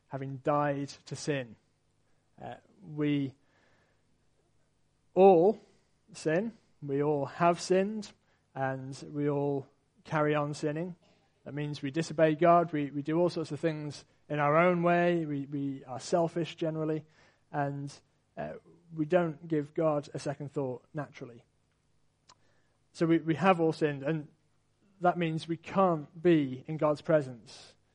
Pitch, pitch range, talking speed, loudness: 150 Hz, 140-165 Hz, 135 wpm, -30 LUFS